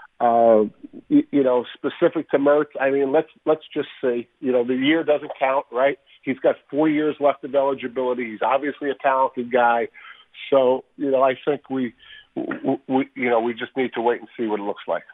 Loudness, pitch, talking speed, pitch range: -22 LUFS, 135 Hz, 200 wpm, 125-150 Hz